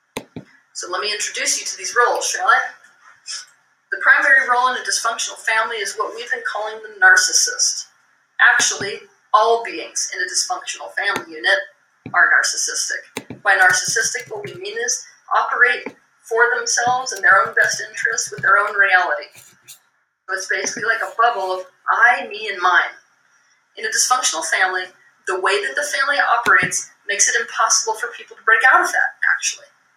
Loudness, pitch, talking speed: -17 LUFS, 270 Hz, 170 wpm